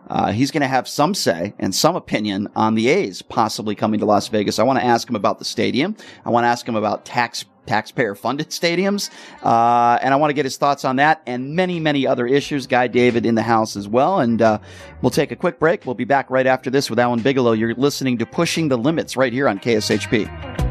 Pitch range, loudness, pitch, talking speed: 115-140 Hz, -19 LUFS, 125 Hz, 245 wpm